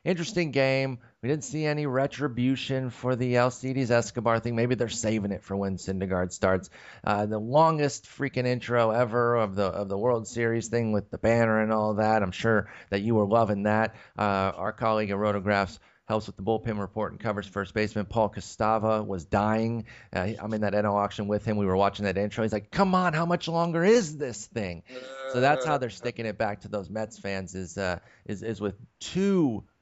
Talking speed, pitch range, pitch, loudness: 210 wpm, 100-125 Hz, 110 Hz, -27 LUFS